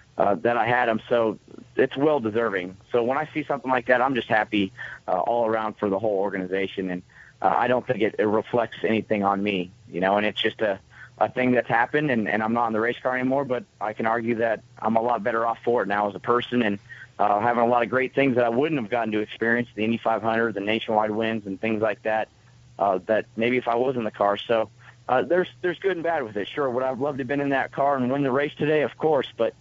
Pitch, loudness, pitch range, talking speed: 115 Hz, -24 LUFS, 110-130 Hz, 270 wpm